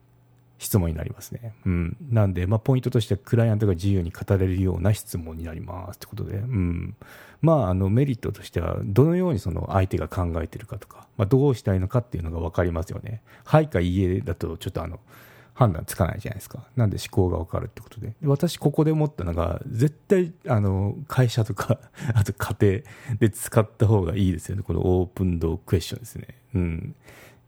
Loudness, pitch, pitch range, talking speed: -24 LUFS, 105 Hz, 90-125 Hz, 435 characters per minute